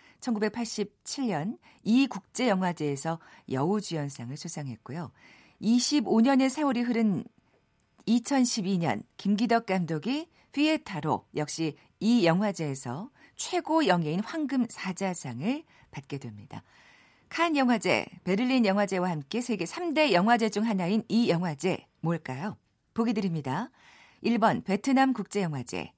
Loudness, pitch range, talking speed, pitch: -28 LUFS, 165-245 Hz, 245 characters per minute, 205 Hz